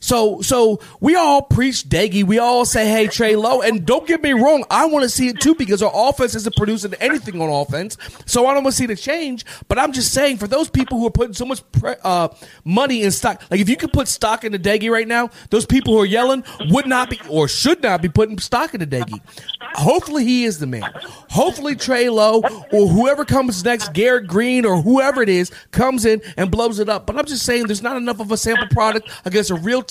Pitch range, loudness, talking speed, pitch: 210-255 Hz, -17 LUFS, 245 wpm, 230 Hz